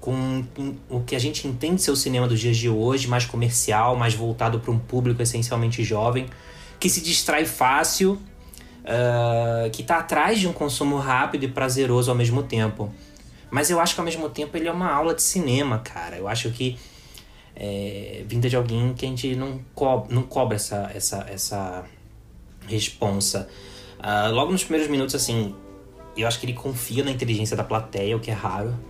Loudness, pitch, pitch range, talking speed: -23 LUFS, 120 Hz, 110-135 Hz, 185 wpm